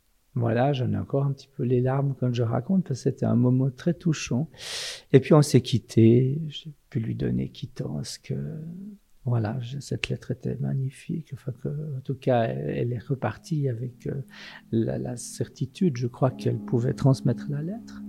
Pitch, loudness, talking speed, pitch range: 130 Hz, -26 LUFS, 175 wpm, 120-145 Hz